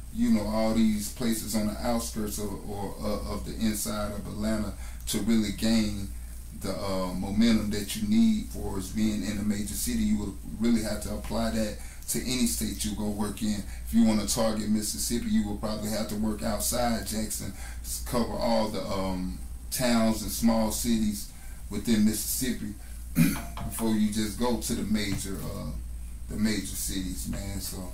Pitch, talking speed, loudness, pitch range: 105 Hz, 175 wpm, -29 LUFS, 95-110 Hz